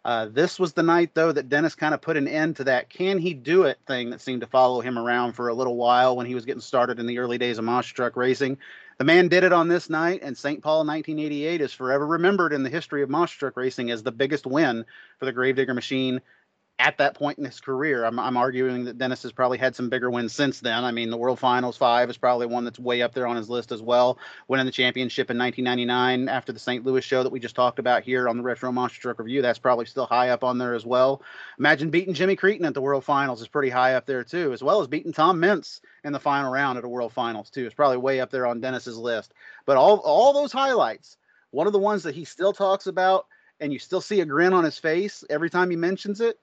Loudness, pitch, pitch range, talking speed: -23 LUFS, 130 Hz, 125-155 Hz, 265 wpm